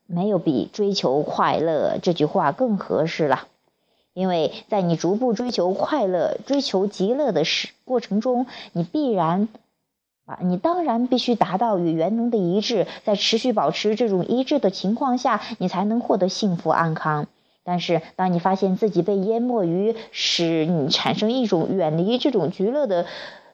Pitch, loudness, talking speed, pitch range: 205 Hz, -22 LUFS, 245 characters per minute, 180-235 Hz